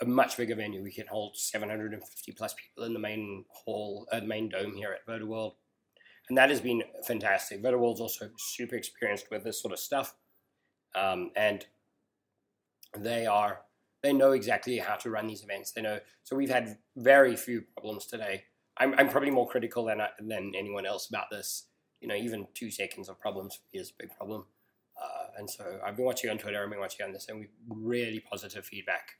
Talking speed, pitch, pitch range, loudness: 200 wpm, 110 Hz, 105-120 Hz, -32 LUFS